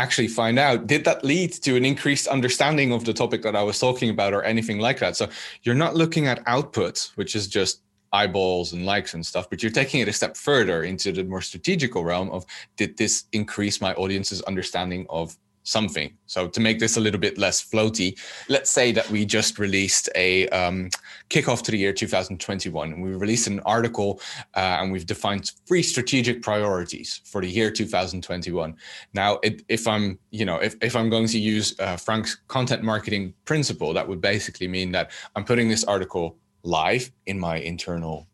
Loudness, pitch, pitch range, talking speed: -23 LUFS, 105 Hz, 95-115 Hz, 195 wpm